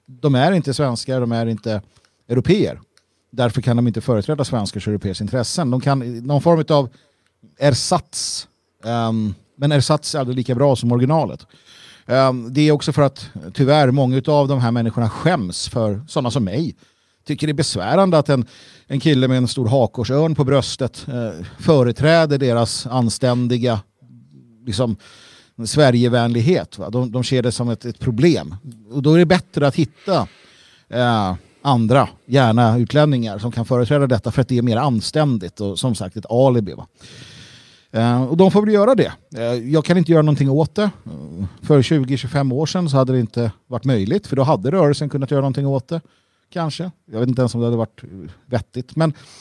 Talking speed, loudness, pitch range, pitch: 175 wpm, -18 LUFS, 115-145 Hz, 125 Hz